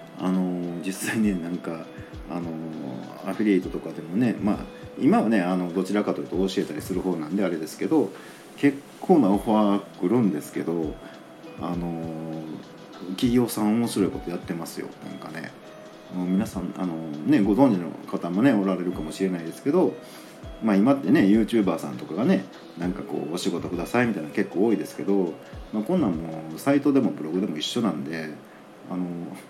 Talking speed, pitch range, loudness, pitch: 340 characters per minute, 85-100 Hz, -25 LUFS, 90 Hz